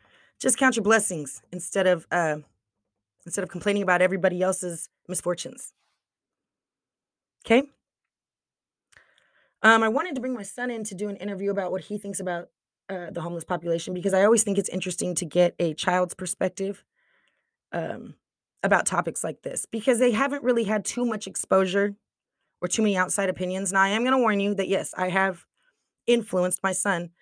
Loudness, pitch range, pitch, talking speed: -25 LUFS, 180-215 Hz, 195 Hz, 175 wpm